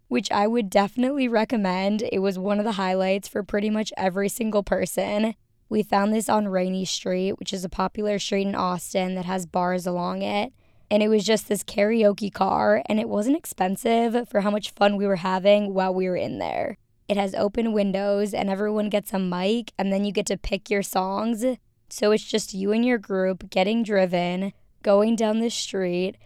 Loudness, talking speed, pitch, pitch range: -24 LUFS, 200 wpm, 200 Hz, 190-215 Hz